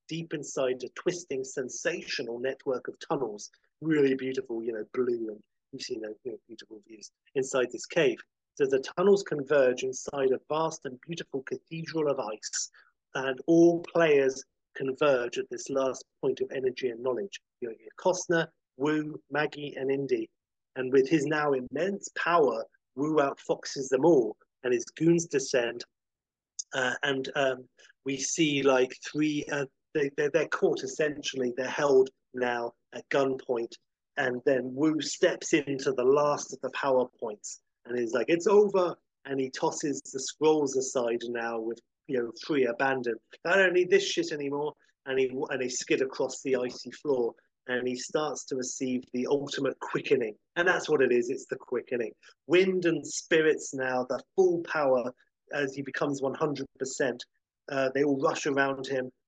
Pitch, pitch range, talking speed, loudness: 145 Hz, 130-185 Hz, 165 wpm, -29 LUFS